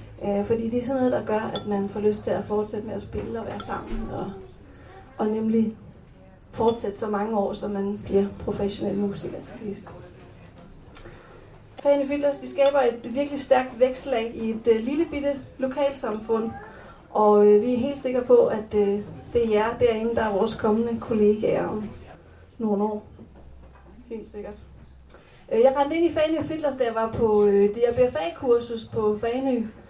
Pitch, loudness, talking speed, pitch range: 225 Hz, -24 LUFS, 165 wpm, 205-255 Hz